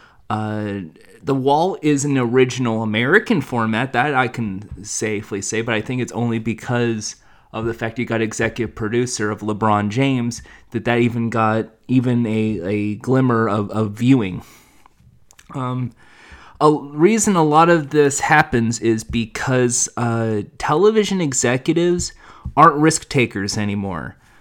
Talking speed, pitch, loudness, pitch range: 140 wpm, 120 Hz, -18 LUFS, 110-135 Hz